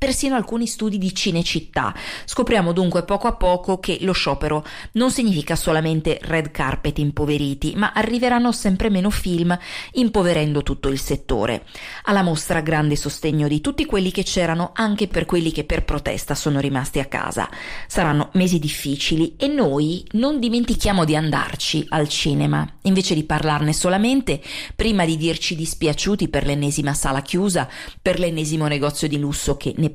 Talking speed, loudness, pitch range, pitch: 155 wpm, -21 LUFS, 150-195 Hz, 165 Hz